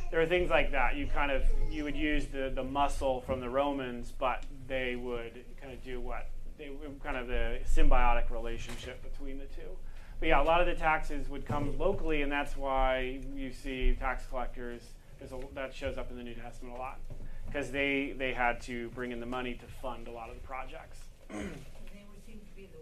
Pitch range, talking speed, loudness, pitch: 120-140 Hz, 200 wpm, -34 LUFS, 130 Hz